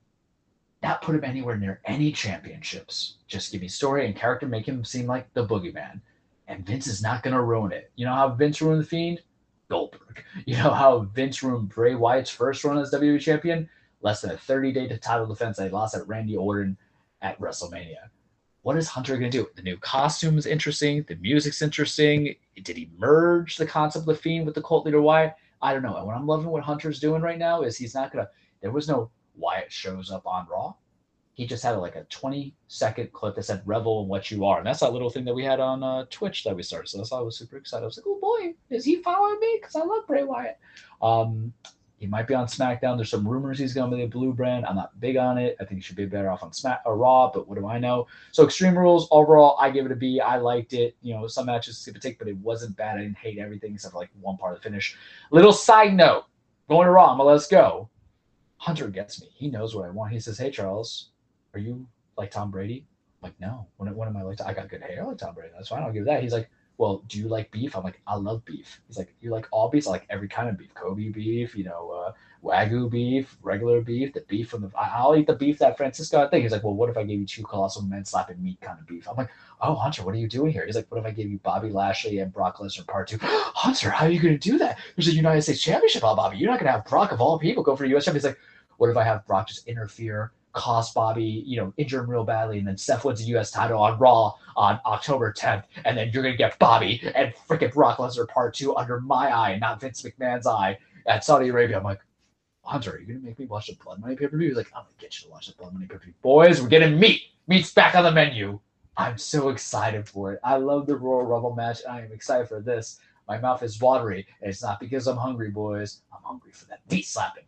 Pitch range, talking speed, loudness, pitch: 105-145 Hz, 260 wpm, -24 LUFS, 120 Hz